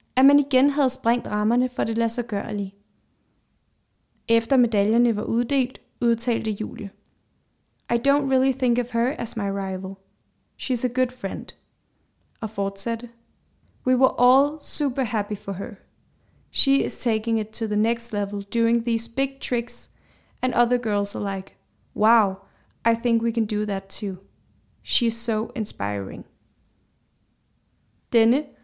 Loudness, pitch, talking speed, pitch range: -23 LUFS, 230 Hz, 140 wpm, 205-245 Hz